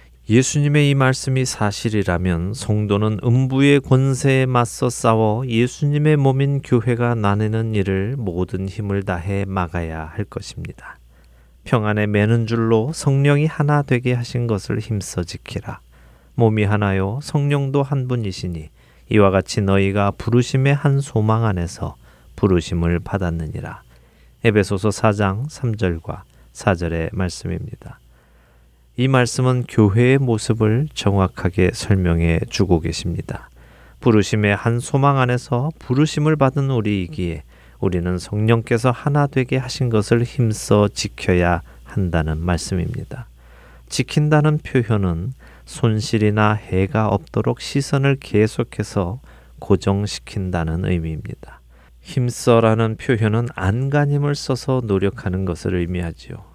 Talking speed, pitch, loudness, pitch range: 275 characters per minute, 105 Hz, -19 LUFS, 90-125 Hz